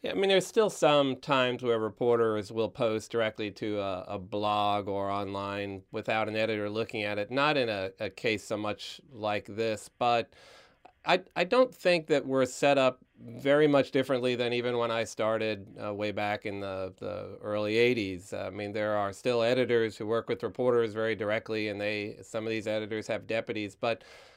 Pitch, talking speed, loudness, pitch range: 110 Hz, 195 wpm, -30 LUFS, 105-125 Hz